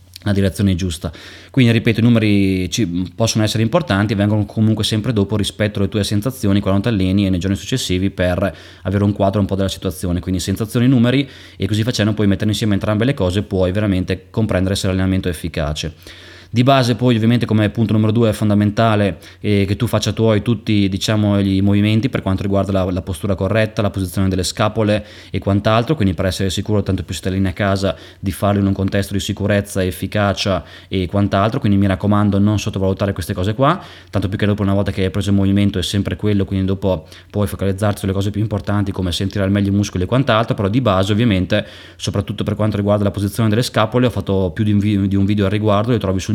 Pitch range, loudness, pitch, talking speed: 95-110 Hz, -17 LUFS, 100 Hz, 215 wpm